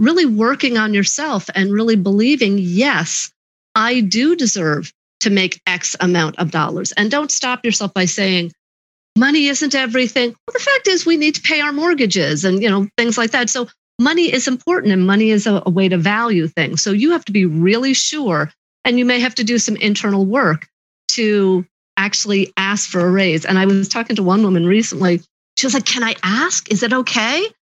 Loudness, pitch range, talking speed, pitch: -15 LUFS, 190-255 Hz, 200 wpm, 220 Hz